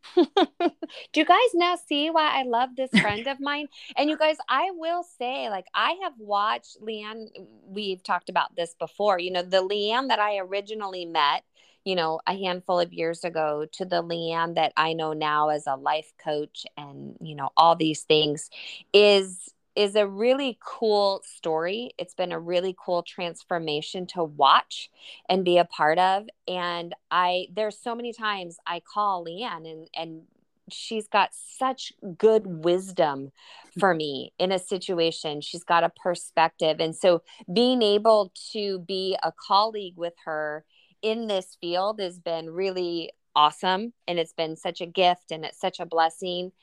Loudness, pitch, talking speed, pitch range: -25 LUFS, 185 Hz, 170 wpm, 165-215 Hz